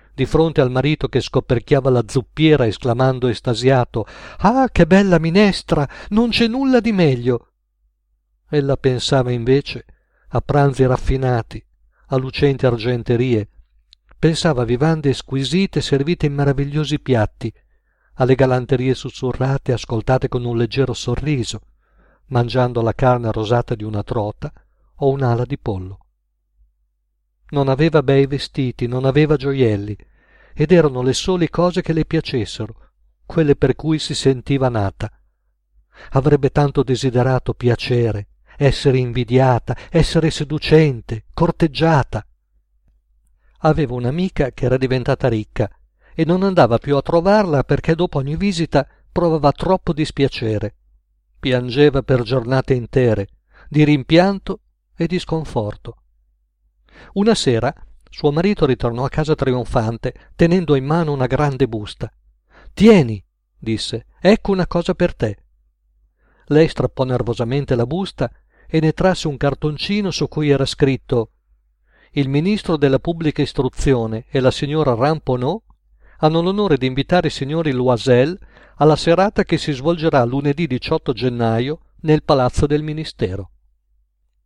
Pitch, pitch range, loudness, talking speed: 135 Hz, 115-155 Hz, -18 LUFS, 125 wpm